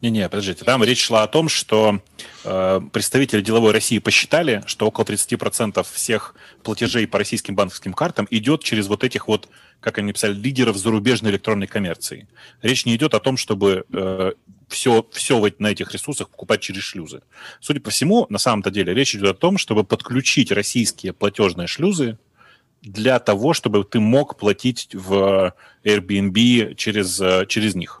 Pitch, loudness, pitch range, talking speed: 110 Hz, -19 LUFS, 100-120 Hz, 165 wpm